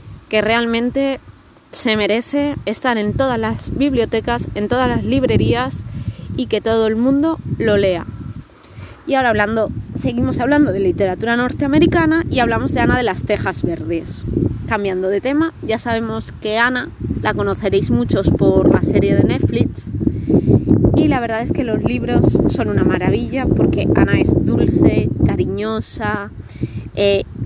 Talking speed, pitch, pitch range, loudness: 145 wpm, 220 Hz, 185-250 Hz, -17 LUFS